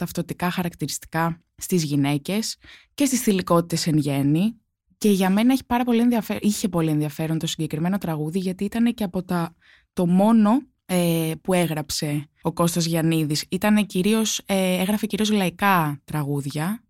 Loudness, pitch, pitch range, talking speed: -22 LUFS, 180 Hz, 160-210 Hz, 140 wpm